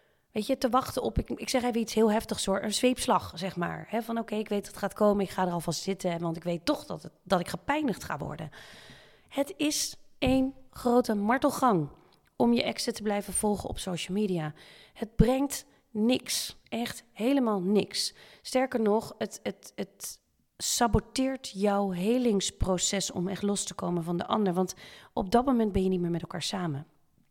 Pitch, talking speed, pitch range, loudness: 210 Hz, 200 wpm, 190-245 Hz, -29 LUFS